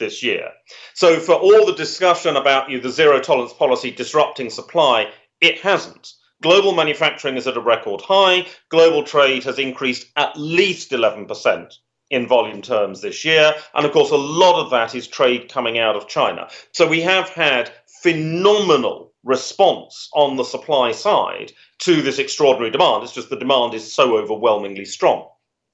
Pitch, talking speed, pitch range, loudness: 160 Hz, 165 wpm, 135-195 Hz, -17 LUFS